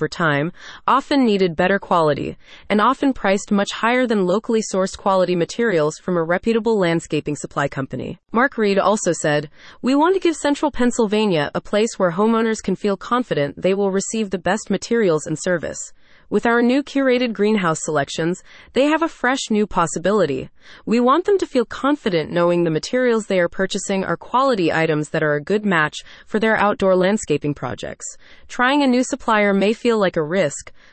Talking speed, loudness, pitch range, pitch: 180 wpm, -19 LUFS, 170-235 Hz, 200 Hz